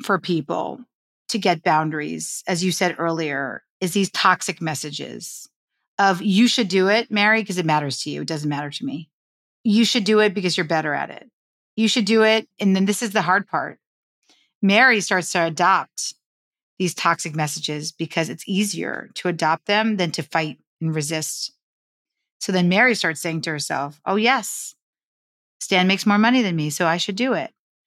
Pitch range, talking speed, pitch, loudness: 160-215 Hz, 185 wpm, 185 Hz, -20 LUFS